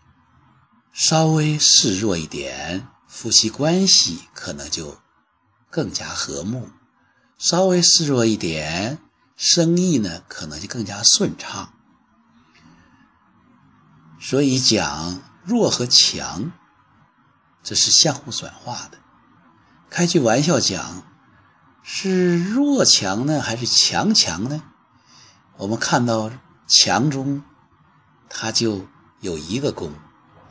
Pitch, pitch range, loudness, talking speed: 140 Hz, 110-175 Hz, -18 LUFS, 140 characters per minute